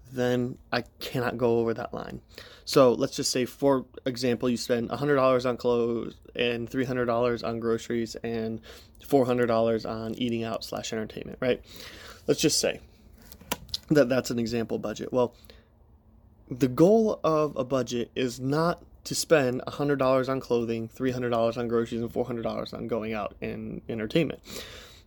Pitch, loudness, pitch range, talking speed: 120 Hz, -27 LUFS, 115-130 Hz, 145 wpm